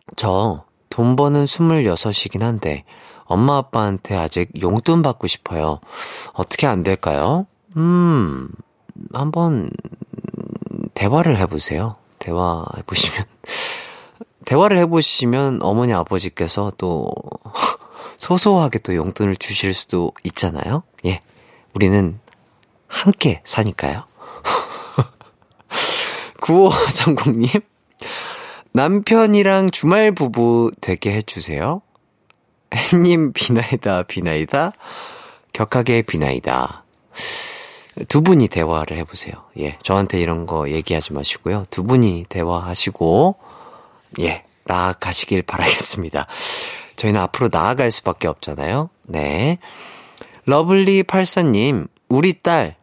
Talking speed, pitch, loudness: 225 characters per minute, 120 Hz, -18 LUFS